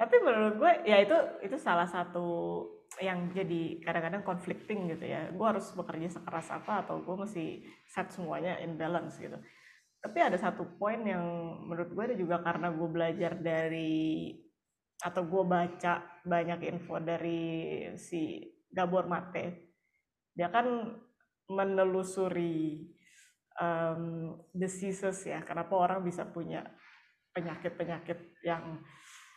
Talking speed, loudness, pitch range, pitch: 125 wpm, -34 LUFS, 170-190 Hz, 175 Hz